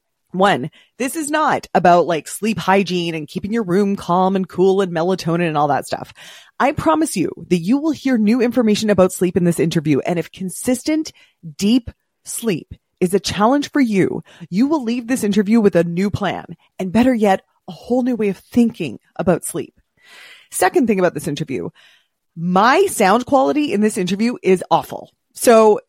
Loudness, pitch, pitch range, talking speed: -17 LUFS, 200 Hz, 180-240 Hz, 185 wpm